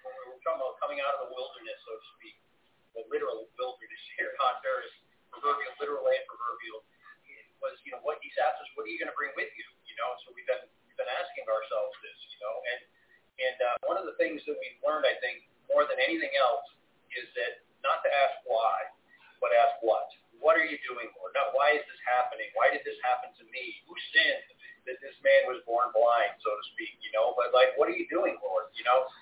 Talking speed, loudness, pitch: 230 wpm, -30 LUFS, 325 Hz